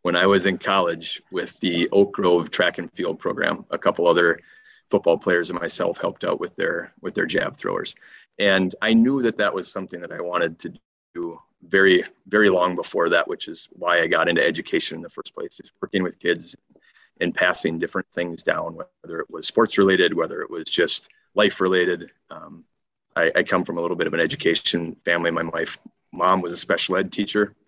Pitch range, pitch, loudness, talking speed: 85-105 Hz, 90 Hz, -22 LUFS, 210 wpm